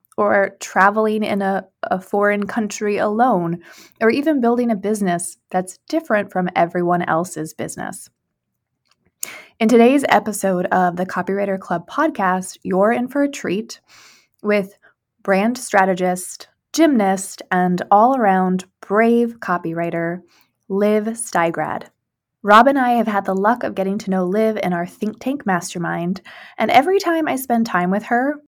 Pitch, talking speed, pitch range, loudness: 200 Hz, 145 wpm, 185-230 Hz, -18 LUFS